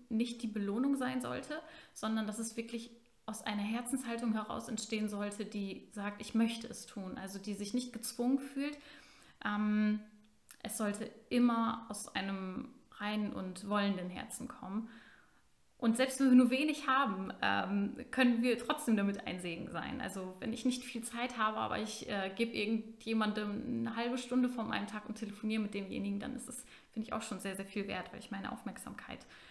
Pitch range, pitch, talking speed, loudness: 210-250 Hz, 225 Hz, 185 wpm, -37 LUFS